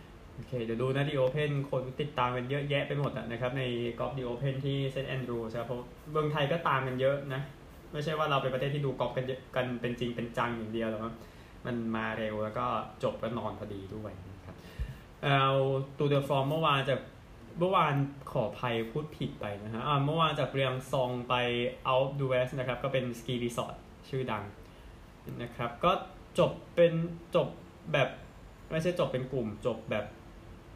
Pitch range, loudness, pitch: 115-140 Hz, -32 LUFS, 125 Hz